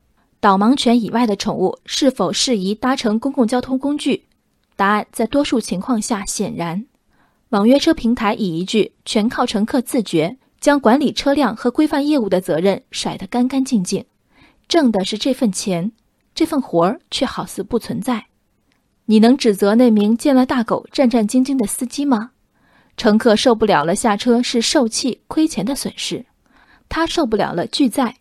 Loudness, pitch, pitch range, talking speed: -17 LUFS, 235 Hz, 205-265 Hz, 255 characters per minute